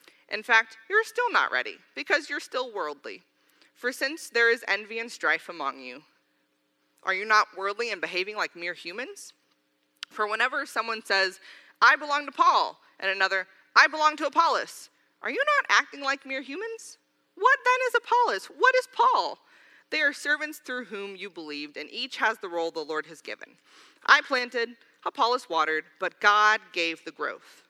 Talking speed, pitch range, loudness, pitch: 175 wpm, 180-295 Hz, -25 LUFS, 230 Hz